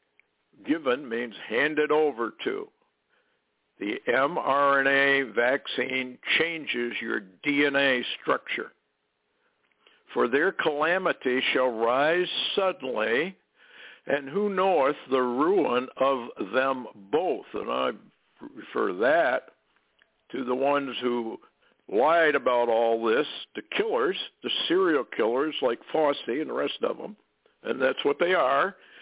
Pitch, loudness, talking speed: 140 Hz, -26 LUFS, 115 wpm